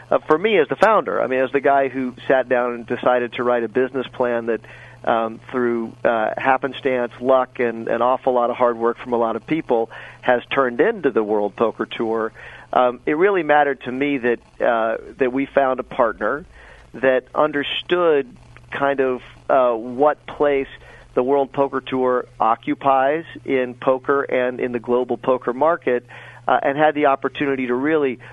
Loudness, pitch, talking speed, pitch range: -20 LUFS, 130 Hz, 180 wpm, 120-140 Hz